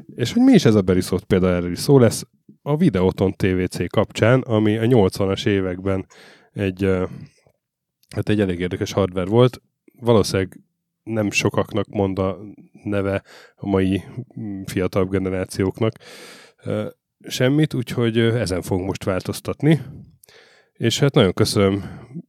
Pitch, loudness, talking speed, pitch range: 100 Hz, -20 LUFS, 125 wpm, 95-120 Hz